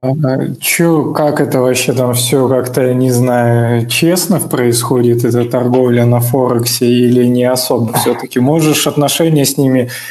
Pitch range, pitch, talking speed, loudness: 120-145 Hz, 125 Hz, 140 wpm, -11 LUFS